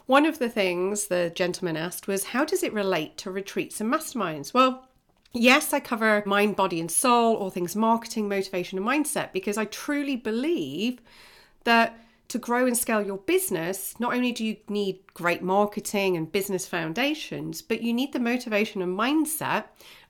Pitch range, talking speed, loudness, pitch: 190-245 Hz, 175 wpm, -25 LUFS, 215 Hz